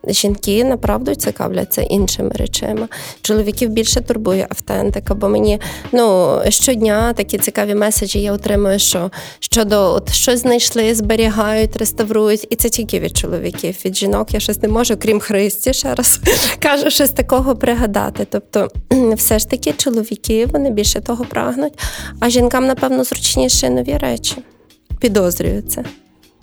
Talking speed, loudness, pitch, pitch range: 135 wpm, -15 LUFS, 220 Hz, 205-245 Hz